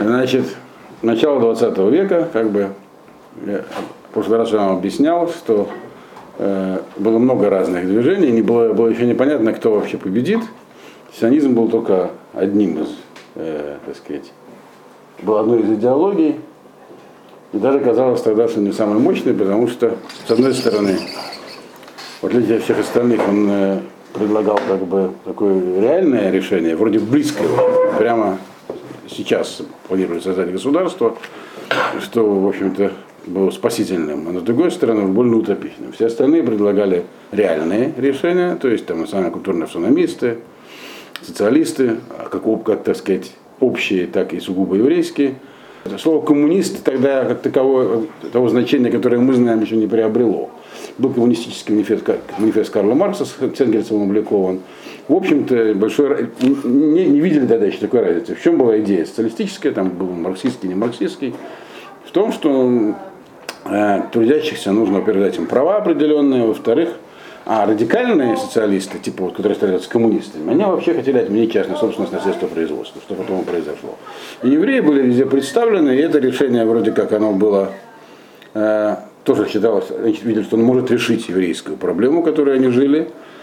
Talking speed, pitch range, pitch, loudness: 145 wpm, 105-140 Hz, 115 Hz, -16 LUFS